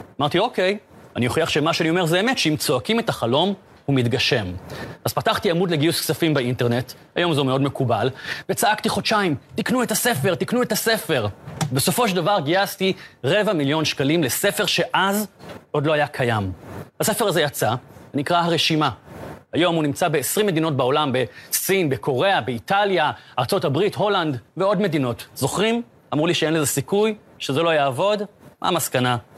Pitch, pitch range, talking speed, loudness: 160 Hz, 140-195 Hz, 155 wpm, -21 LUFS